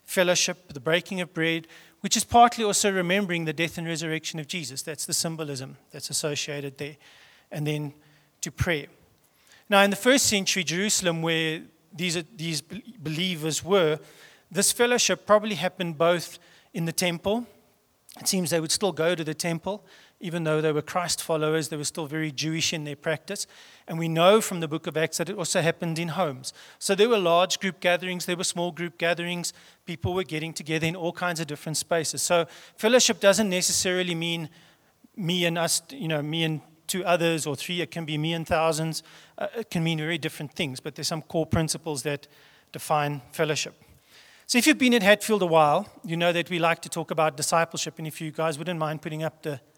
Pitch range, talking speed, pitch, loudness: 155-180 Hz, 200 wpm, 170 Hz, -25 LUFS